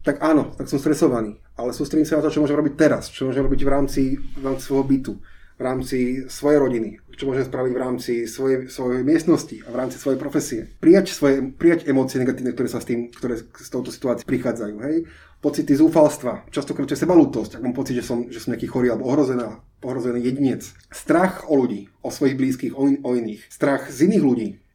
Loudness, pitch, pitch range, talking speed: -21 LUFS, 130 Hz, 125-145 Hz, 210 wpm